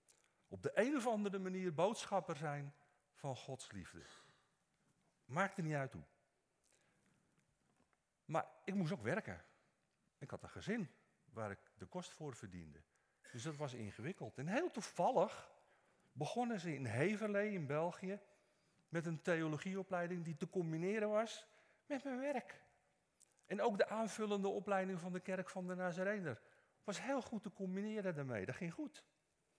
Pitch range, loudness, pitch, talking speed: 150-200 Hz, -43 LUFS, 185 Hz, 150 wpm